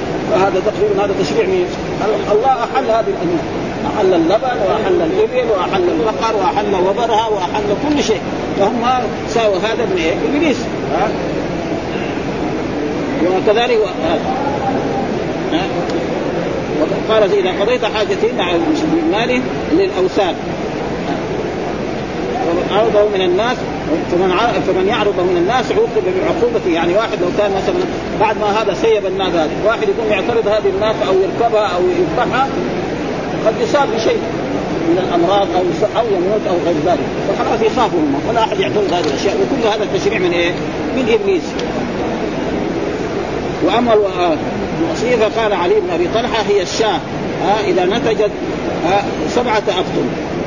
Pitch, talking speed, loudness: 220 Hz, 125 wpm, -16 LUFS